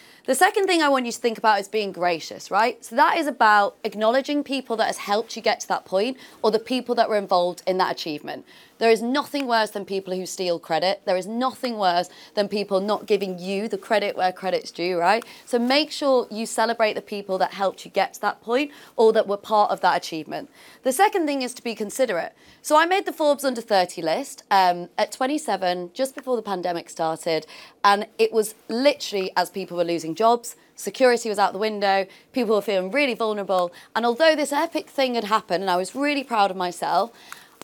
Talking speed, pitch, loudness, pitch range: 220 wpm, 215 Hz, -23 LUFS, 190-255 Hz